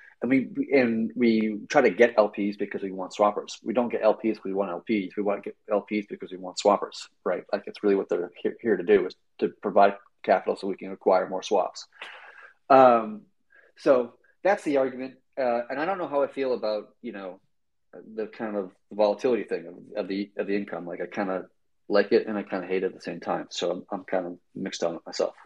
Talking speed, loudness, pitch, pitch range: 235 wpm, -26 LUFS, 105 Hz, 100-130 Hz